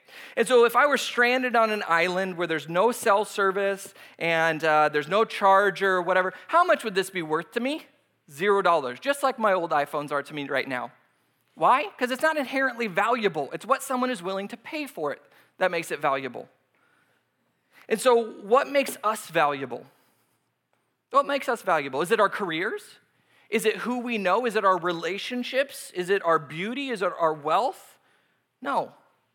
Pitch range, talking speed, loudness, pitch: 165-250 Hz, 185 wpm, -25 LUFS, 200 Hz